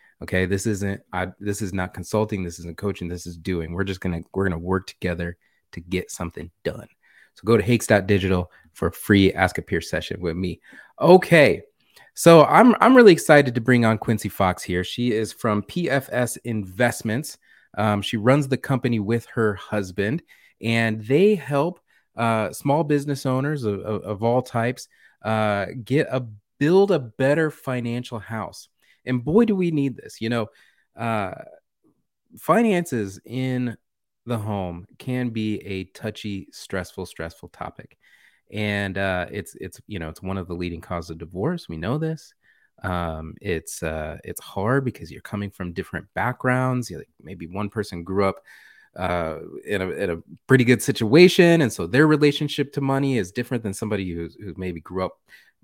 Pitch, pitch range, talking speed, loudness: 110 Hz, 95-130 Hz, 175 wpm, -22 LUFS